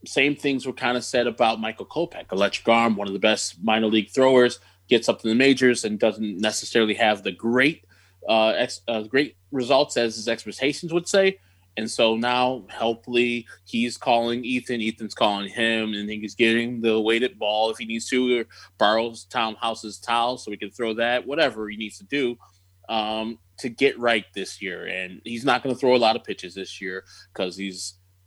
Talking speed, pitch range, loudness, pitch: 200 wpm, 105-120 Hz, -23 LUFS, 110 Hz